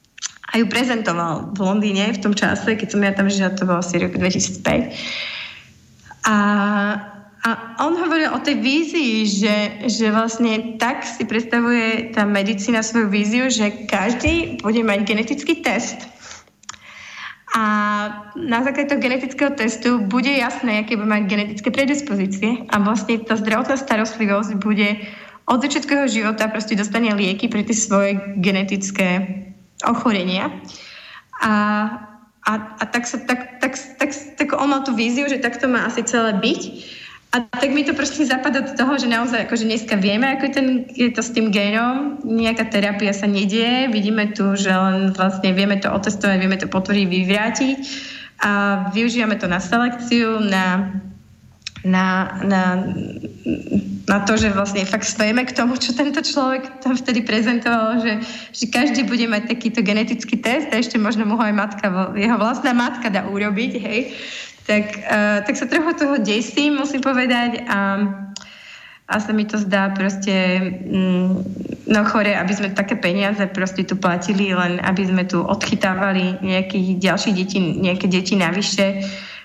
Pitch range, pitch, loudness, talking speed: 200-240 Hz, 215 Hz, -19 LUFS, 155 wpm